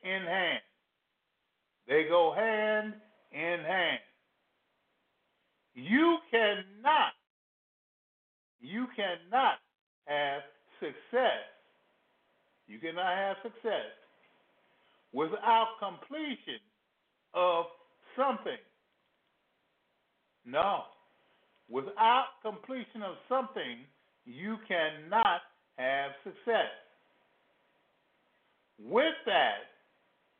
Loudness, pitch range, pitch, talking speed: -31 LUFS, 170-255 Hz, 215 Hz, 65 wpm